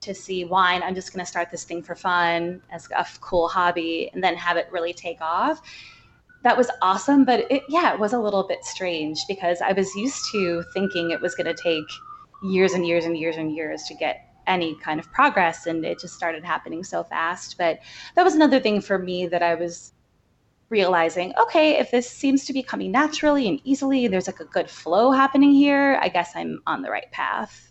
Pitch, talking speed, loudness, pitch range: 185 Hz, 215 wpm, -22 LUFS, 170-265 Hz